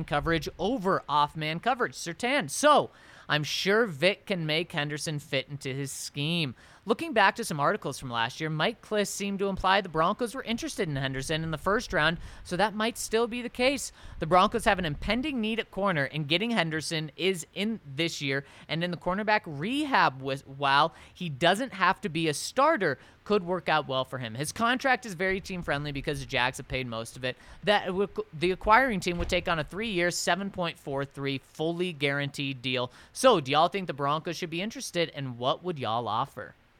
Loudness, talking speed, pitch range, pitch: -28 LUFS, 200 wpm, 145-205 Hz, 170 Hz